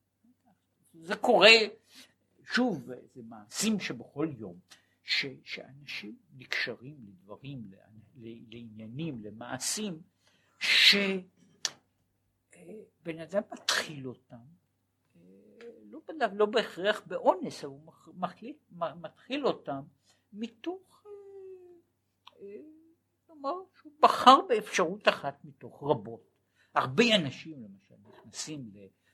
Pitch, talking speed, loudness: 175 Hz, 80 wpm, -28 LUFS